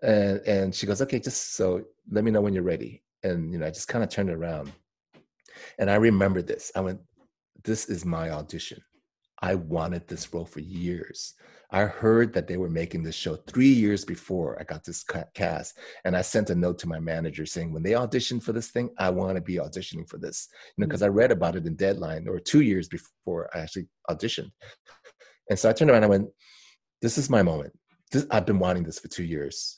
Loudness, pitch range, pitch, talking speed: -27 LUFS, 85-105 Hz, 95 Hz, 225 wpm